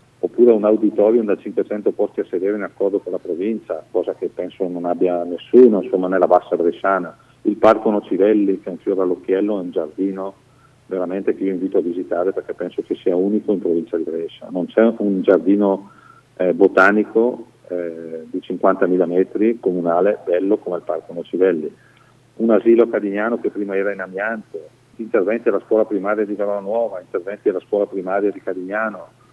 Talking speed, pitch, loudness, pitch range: 180 wpm, 100 Hz, -19 LUFS, 95-115 Hz